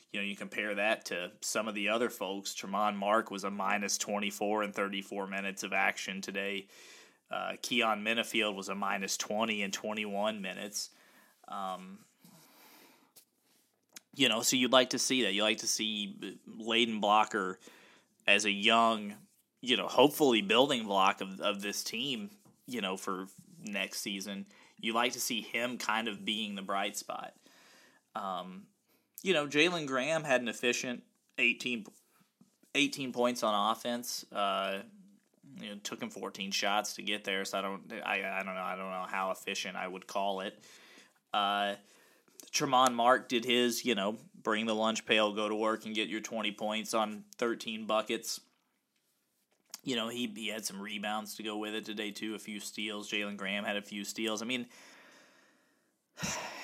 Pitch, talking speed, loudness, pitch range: 105 Hz, 175 wpm, -32 LUFS, 100-115 Hz